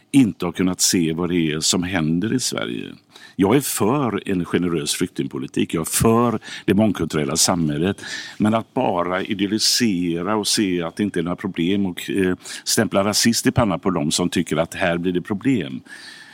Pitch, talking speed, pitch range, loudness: 95 Hz, 185 wpm, 85-110 Hz, -20 LUFS